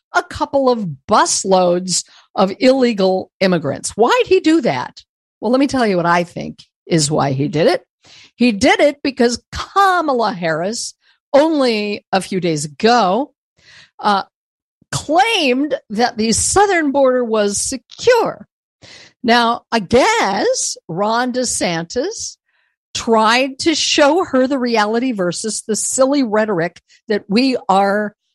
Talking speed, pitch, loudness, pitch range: 130 wpm, 240 Hz, -16 LUFS, 200-280 Hz